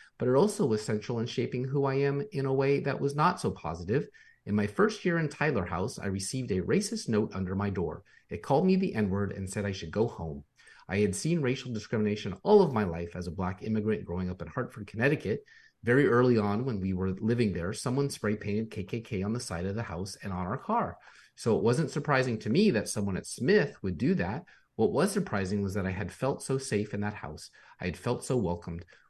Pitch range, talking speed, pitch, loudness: 100-135 Hz, 240 wpm, 110 Hz, -30 LUFS